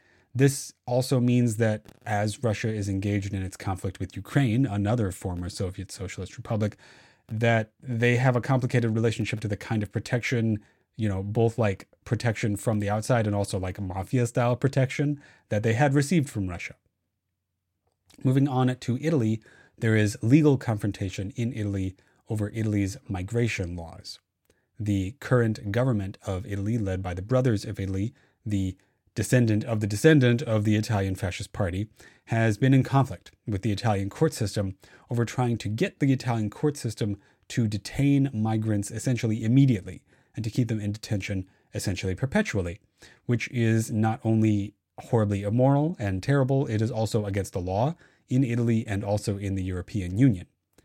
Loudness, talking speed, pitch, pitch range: -26 LUFS, 160 wpm, 110 Hz, 100-125 Hz